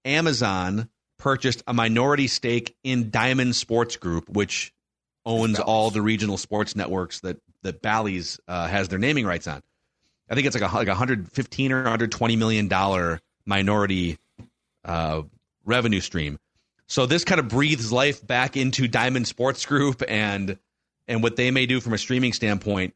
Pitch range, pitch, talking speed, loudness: 100-130 Hz, 115 Hz, 160 wpm, -23 LUFS